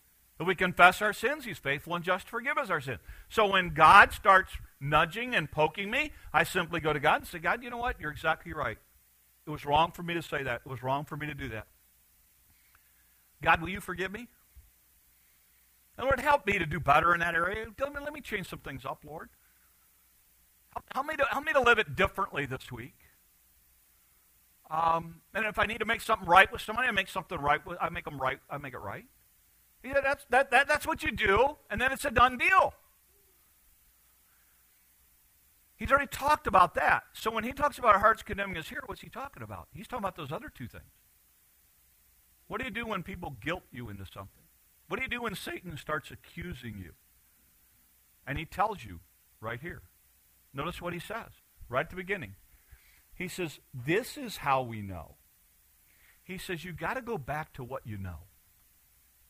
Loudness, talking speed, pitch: -29 LUFS, 205 wpm, 160 Hz